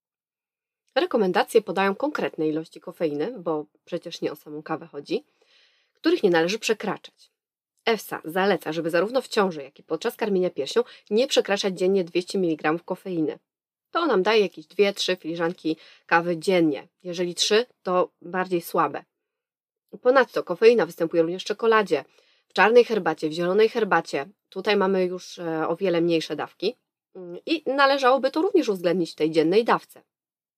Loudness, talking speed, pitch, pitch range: -24 LUFS, 145 wpm, 185 Hz, 165-230 Hz